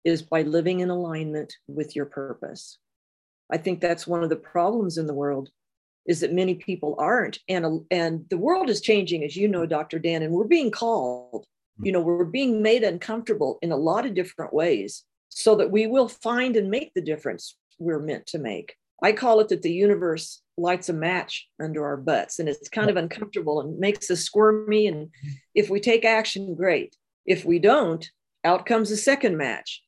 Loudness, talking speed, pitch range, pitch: -24 LUFS, 195 wpm, 160-215 Hz, 180 Hz